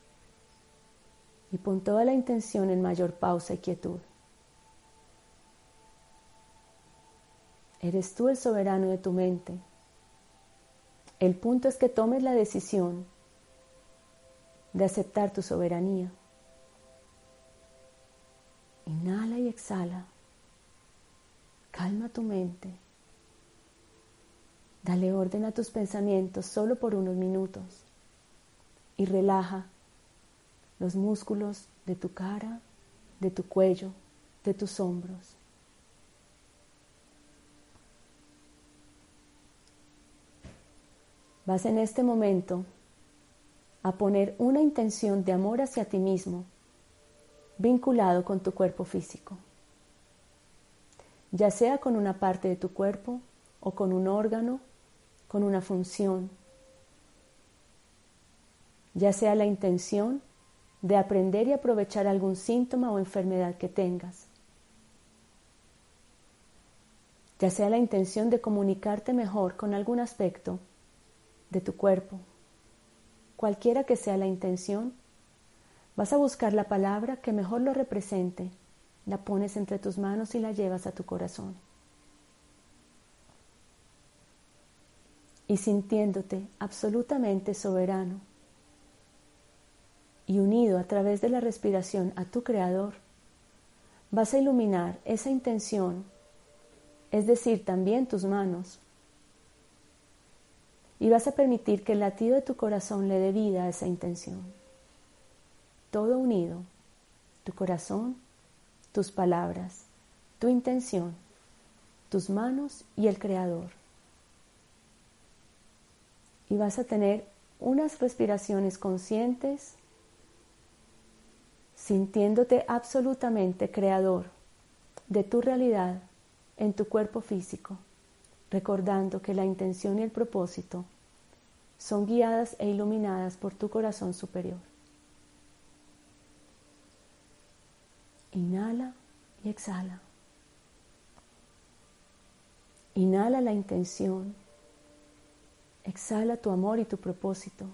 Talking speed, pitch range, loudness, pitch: 95 wpm, 180-215 Hz, -30 LUFS, 195 Hz